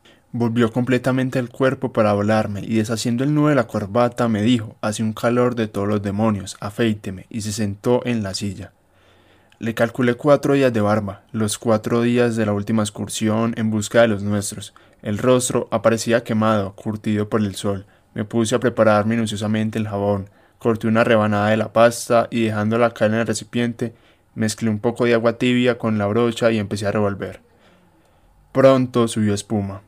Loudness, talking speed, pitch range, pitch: -20 LUFS, 185 wpm, 105-120 Hz, 110 Hz